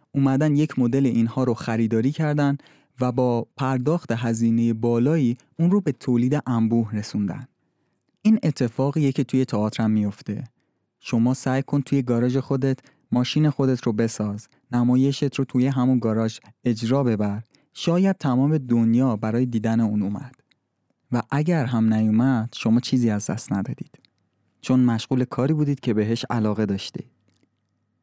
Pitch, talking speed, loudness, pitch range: 125 Hz, 140 wpm, -22 LUFS, 115-140 Hz